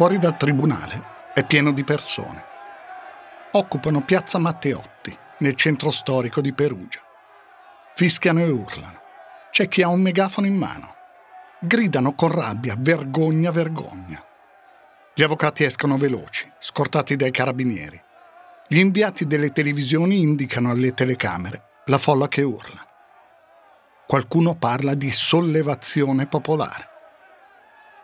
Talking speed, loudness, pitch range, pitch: 115 wpm, -21 LUFS, 140-180 Hz, 150 Hz